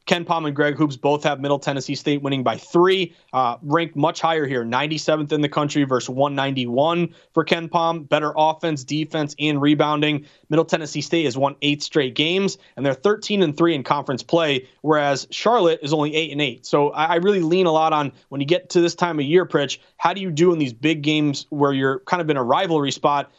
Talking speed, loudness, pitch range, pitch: 225 wpm, -20 LUFS, 140-170 Hz, 150 Hz